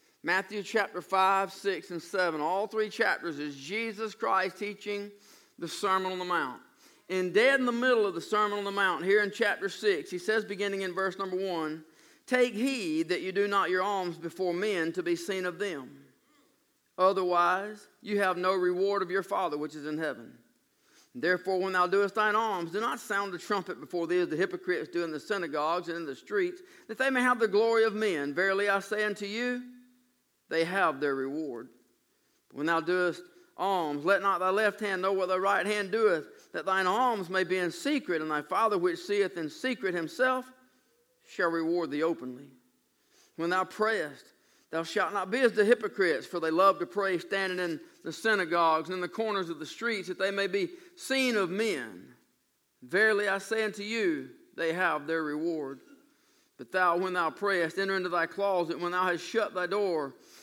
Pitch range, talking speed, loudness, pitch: 175-225 Hz, 200 wpm, -30 LUFS, 195 Hz